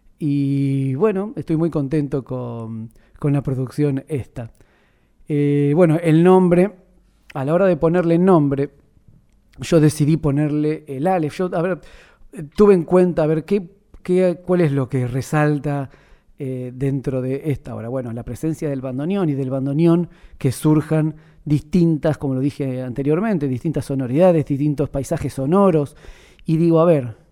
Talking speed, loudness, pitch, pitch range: 155 wpm, -19 LUFS, 150 Hz, 135-170 Hz